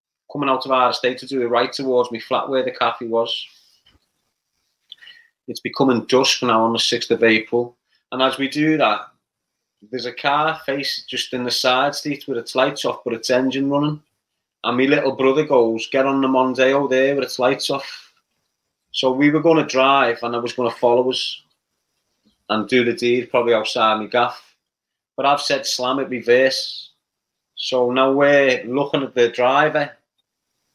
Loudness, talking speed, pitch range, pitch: -19 LUFS, 180 wpm, 120-140 Hz, 130 Hz